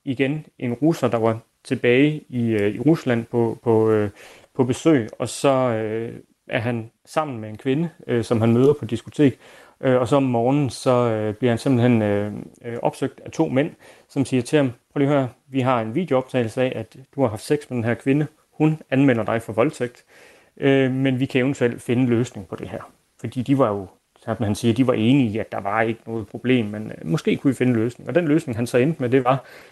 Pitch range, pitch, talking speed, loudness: 115-135 Hz, 125 Hz, 220 wpm, -21 LUFS